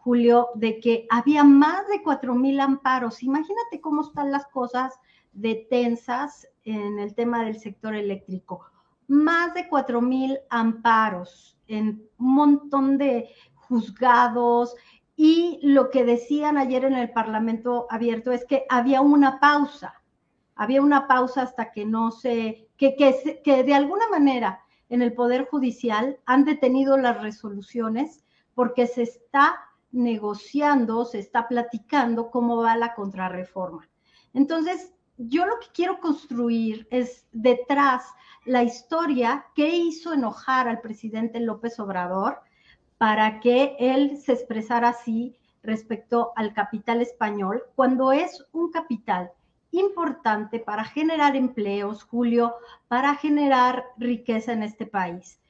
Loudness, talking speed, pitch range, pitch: -23 LUFS, 130 wpm, 225-275 Hz, 245 Hz